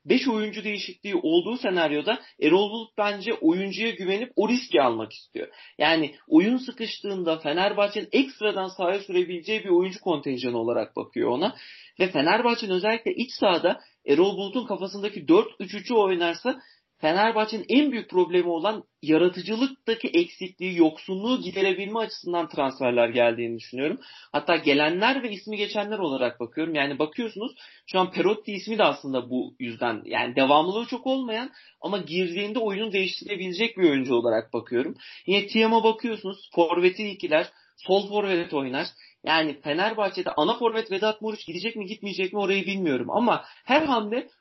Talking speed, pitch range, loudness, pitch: 140 wpm, 175-225 Hz, -25 LUFS, 200 Hz